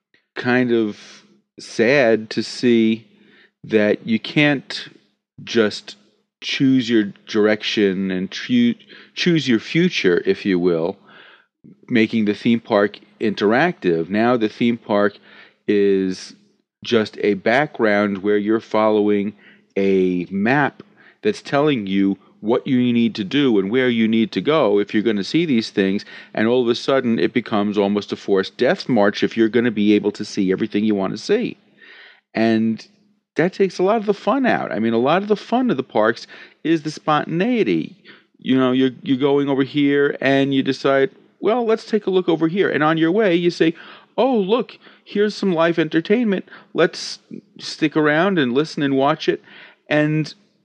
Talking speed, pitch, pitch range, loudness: 170 wpm, 125 Hz, 105-160 Hz, -19 LUFS